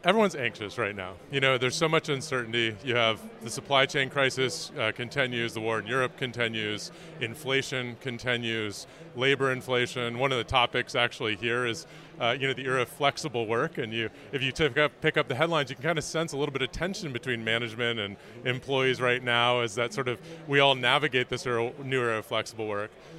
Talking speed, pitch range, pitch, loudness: 210 wpm, 120-140 Hz, 130 Hz, -28 LUFS